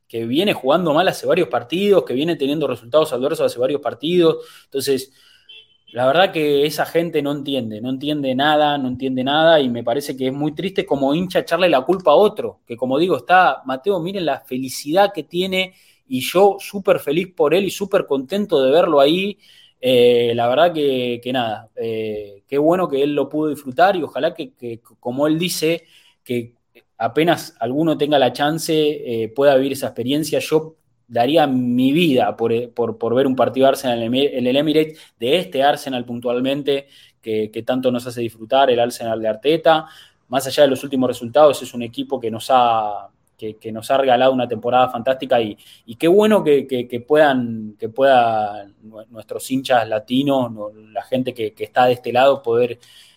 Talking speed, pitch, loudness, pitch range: 190 wpm, 135 Hz, -18 LUFS, 120-160 Hz